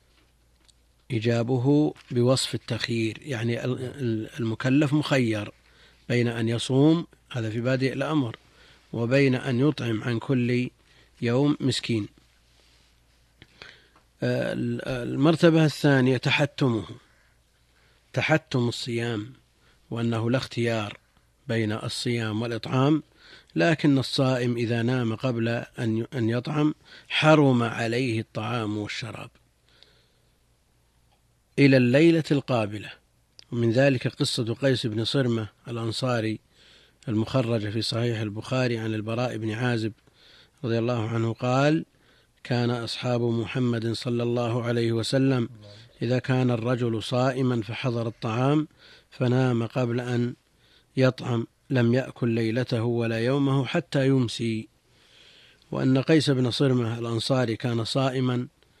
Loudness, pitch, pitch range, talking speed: -25 LUFS, 120 Hz, 115-130 Hz, 95 wpm